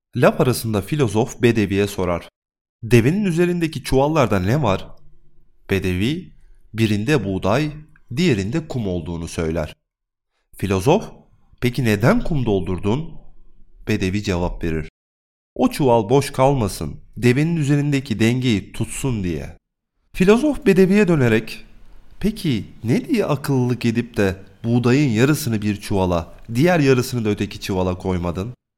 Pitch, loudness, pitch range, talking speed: 110 Hz, -20 LUFS, 95-140 Hz, 110 wpm